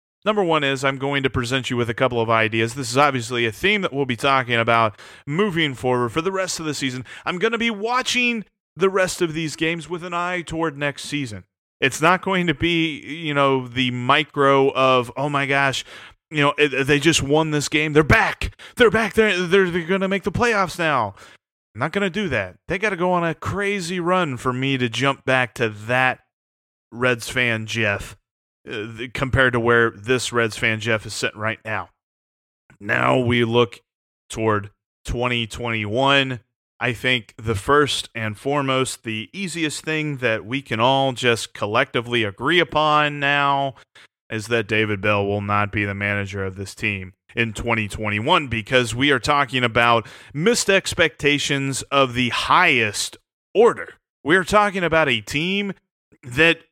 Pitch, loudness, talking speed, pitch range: 135 Hz, -20 LUFS, 180 wpm, 115-160 Hz